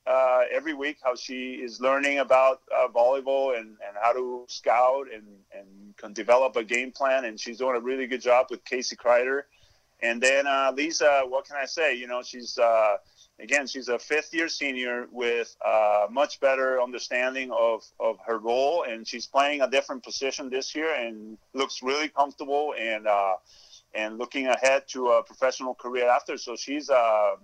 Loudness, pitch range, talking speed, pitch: -26 LUFS, 120-140 Hz, 185 wpm, 130 Hz